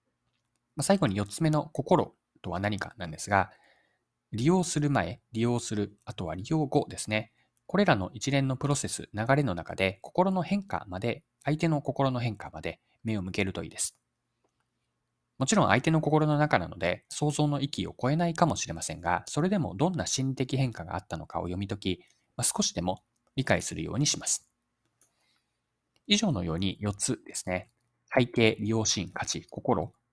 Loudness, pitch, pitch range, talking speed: -29 LUFS, 115 Hz, 95-145 Hz, 325 characters per minute